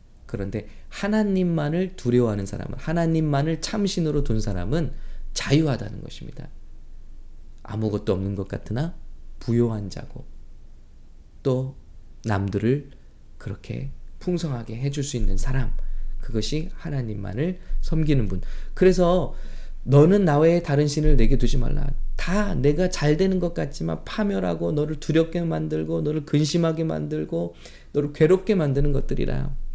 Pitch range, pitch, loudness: 95-155 Hz, 130 Hz, -24 LUFS